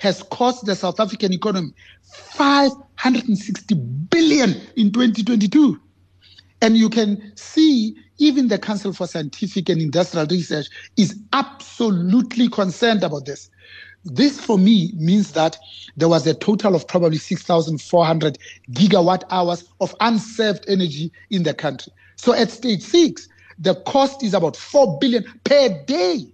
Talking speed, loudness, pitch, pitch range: 135 wpm, -18 LUFS, 205 Hz, 170-235 Hz